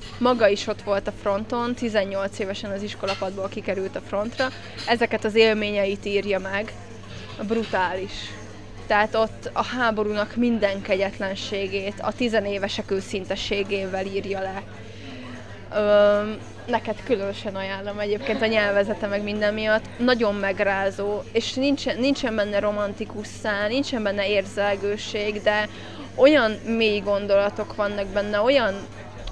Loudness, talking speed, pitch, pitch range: -24 LUFS, 120 wpm, 205 Hz, 195-215 Hz